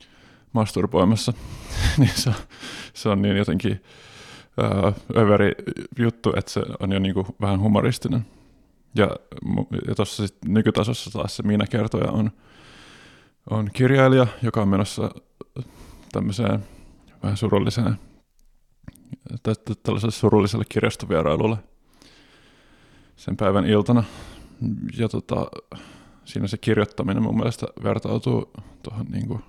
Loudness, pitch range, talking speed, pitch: -23 LUFS, 105-120 Hz, 105 wpm, 110 Hz